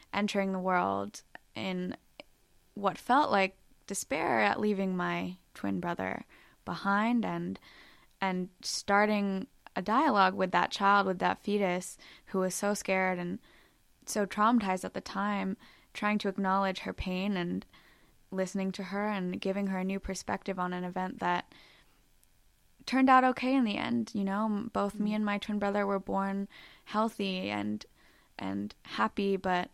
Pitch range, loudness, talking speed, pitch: 185-205 Hz, -31 LUFS, 150 wpm, 195 Hz